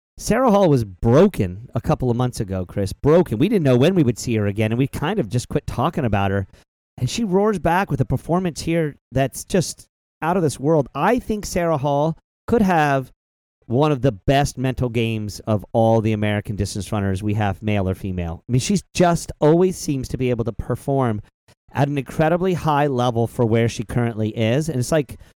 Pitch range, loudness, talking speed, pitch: 110-155 Hz, -20 LUFS, 215 wpm, 125 Hz